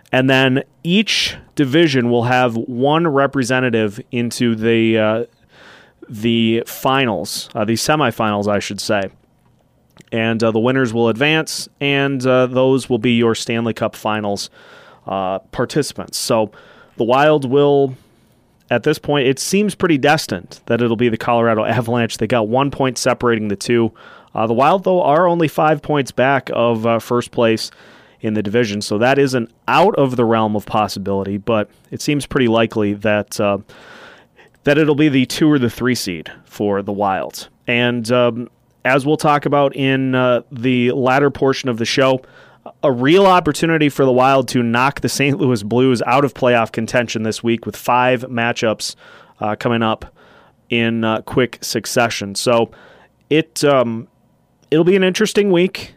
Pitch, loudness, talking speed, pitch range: 125 Hz, -16 LUFS, 165 wpm, 115-140 Hz